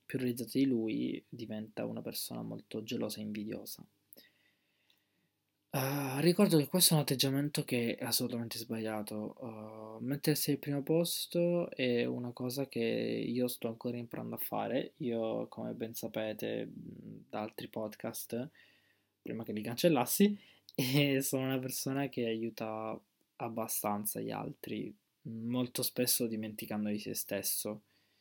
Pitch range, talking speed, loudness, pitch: 110-140 Hz, 135 wpm, -35 LUFS, 120 Hz